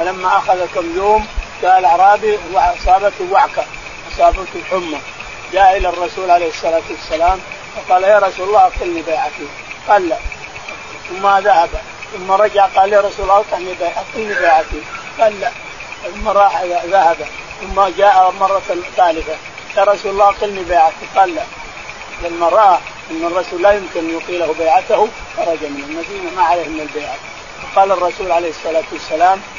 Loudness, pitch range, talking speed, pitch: -14 LUFS, 170-210 Hz, 140 wpm, 190 Hz